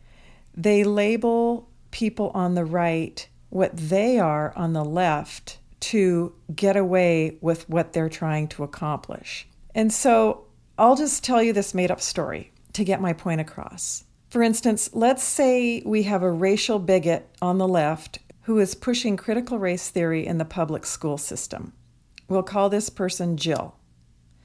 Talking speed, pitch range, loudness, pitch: 155 wpm, 165-215 Hz, -23 LUFS, 185 Hz